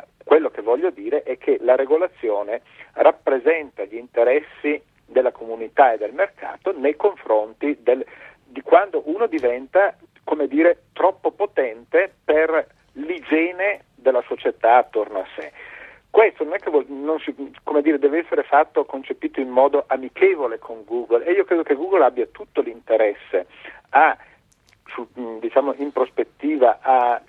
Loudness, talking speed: -20 LUFS, 145 wpm